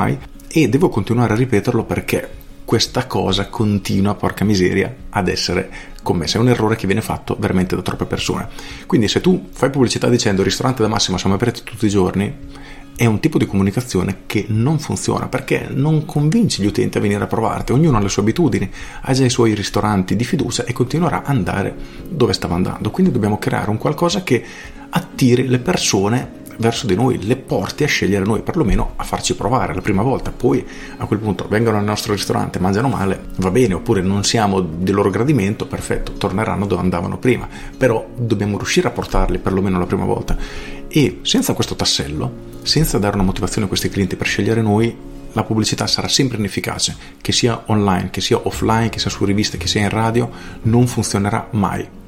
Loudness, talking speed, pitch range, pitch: -18 LUFS, 190 wpm, 95-120 Hz, 105 Hz